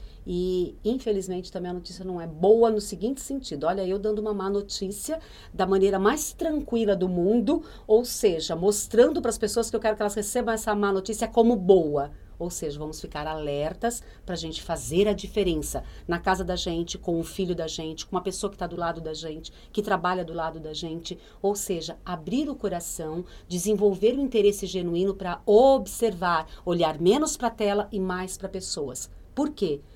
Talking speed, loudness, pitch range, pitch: 195 wpm, -26 LUFS, 175-215 Hz, 195 Hz